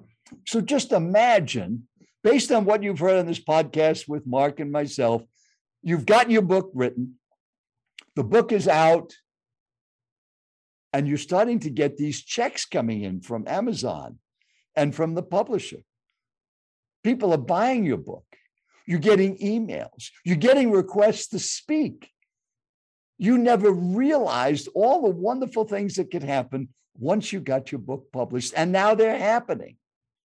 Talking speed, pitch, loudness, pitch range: 145 wpm, 180 Hz, -23 LUFS, 140-220 Hz